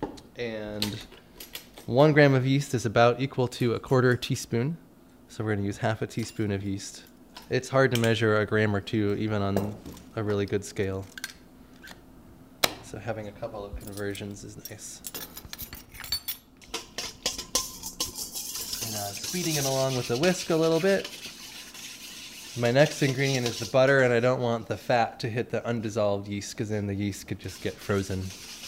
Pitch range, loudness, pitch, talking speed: 100-125 Hz, -27 LUFS, 115 Hz, 165 wpm